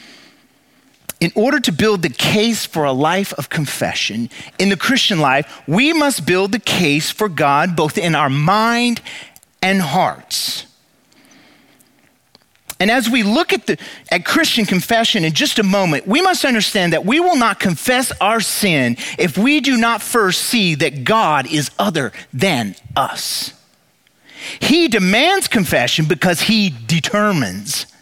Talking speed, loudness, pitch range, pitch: 150 wpm, -15 LUFS, 160-240 Hz, 205 Hz